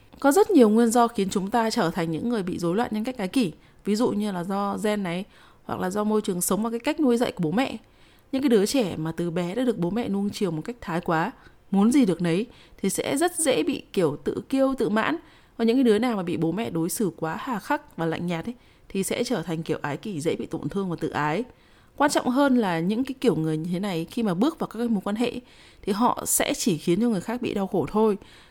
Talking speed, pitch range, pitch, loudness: 285 wpm, 175-240 Hz, 210 Hz, -25 LUFS